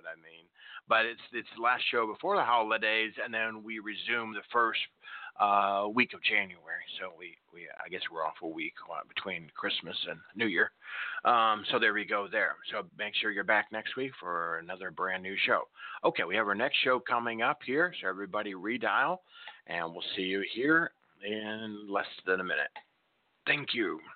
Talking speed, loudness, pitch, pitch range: 190 wpm, -31 LUFS, 105 Hz, 100-110 Hz